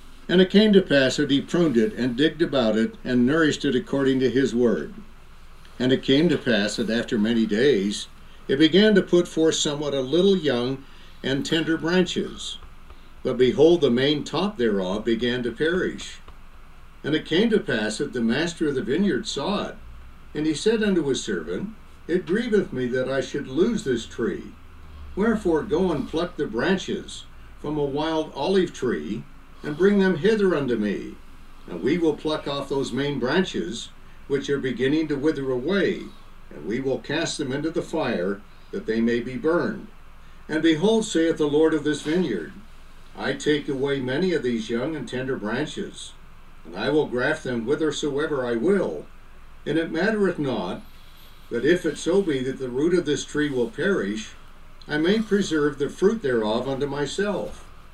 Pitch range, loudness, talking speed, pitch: 125-170 Hz, -23 LUFS, 180 wpm, 145 Hz